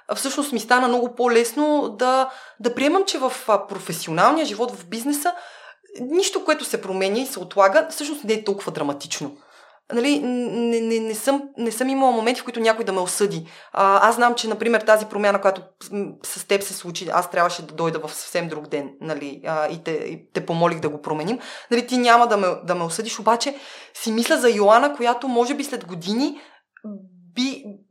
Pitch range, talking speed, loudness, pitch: 185-255 Hz, 195 wpm, -21 LUFS, 225 Hz